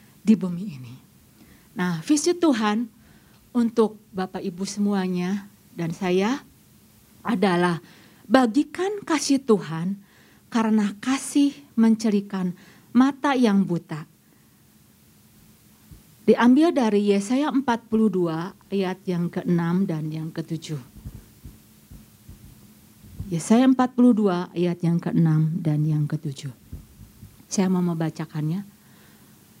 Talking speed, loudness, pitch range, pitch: 85 wpm, -23 LUFS, 170-230 Hz, 195 Hz